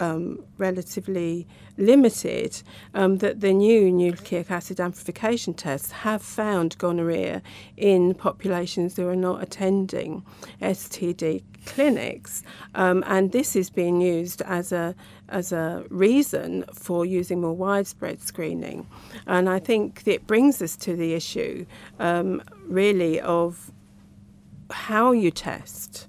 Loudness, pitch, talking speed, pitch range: -24 LUFS, 180 Hz, 125 wpm, 170-195 Hz